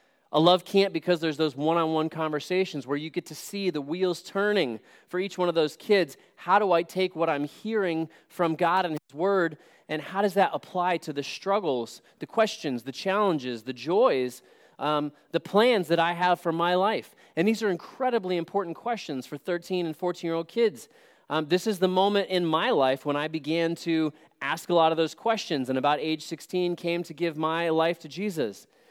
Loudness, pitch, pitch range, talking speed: -27 LUFS, 170 Hz, 155-190 Hz, 210 wpm